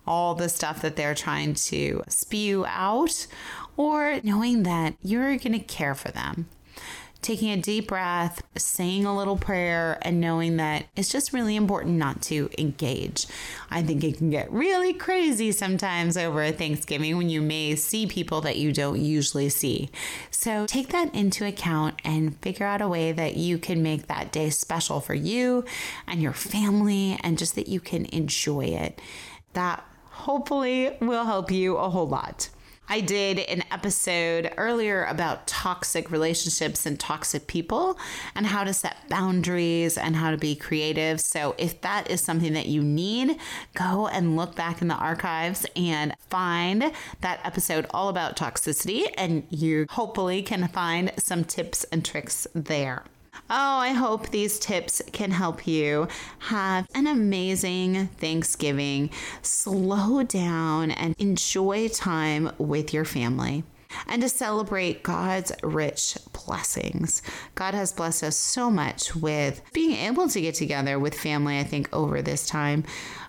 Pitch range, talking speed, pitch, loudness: 155-200 Hz, 155 wpm, 175 Hz, -26 LUFS